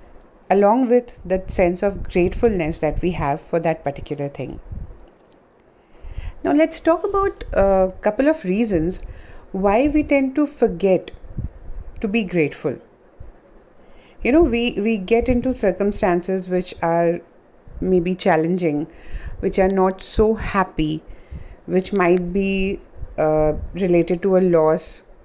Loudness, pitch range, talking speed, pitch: -20 LUFS, 170-225 Hz, 125 wpm, 190 Hz